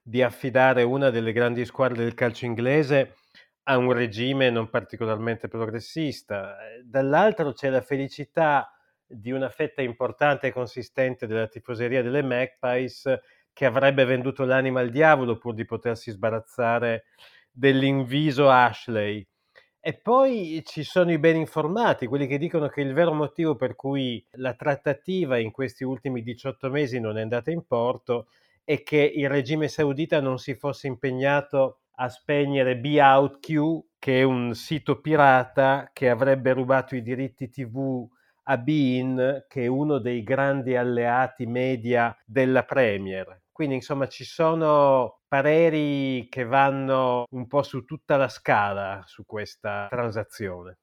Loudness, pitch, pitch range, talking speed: -24 LUFS, 130 Hz, 120-140 Hz, 140 wpm